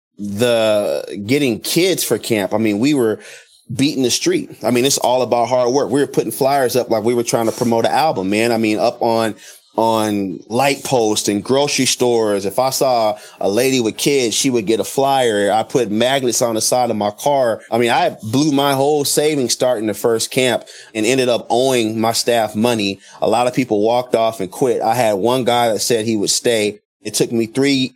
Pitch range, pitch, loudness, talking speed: 105-125 Hz, 115 Hz, -16 LUFS, 220 wpm